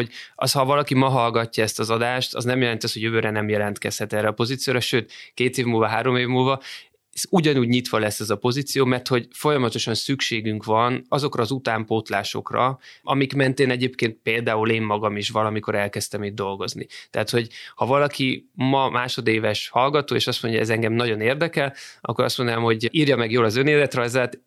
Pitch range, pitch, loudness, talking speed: 110-130 Hz, 120 Hz, -22 LUFS, 190 wpm